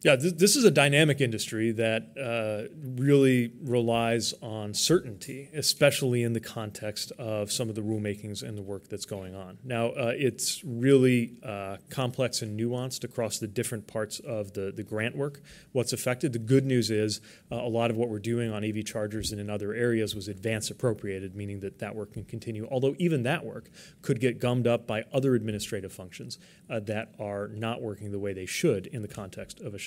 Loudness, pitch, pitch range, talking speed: -28 LUFS, 115 Hz, 105-130 Hz, 200 wpm